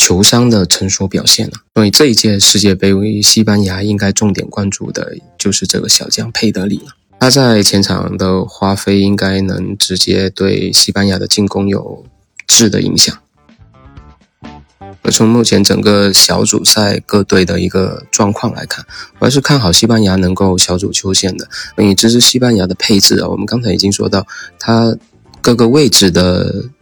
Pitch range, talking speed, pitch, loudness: 95-110 Hz, 265 characters per minute, 100 Hz, -10 LUFS